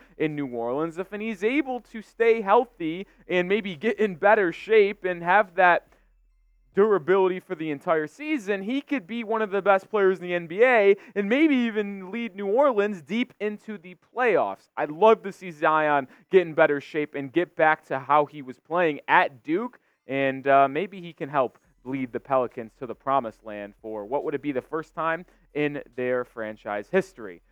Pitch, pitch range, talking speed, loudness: 175 Hz, 140-210 Hz, 190 wpm, -24 LUFS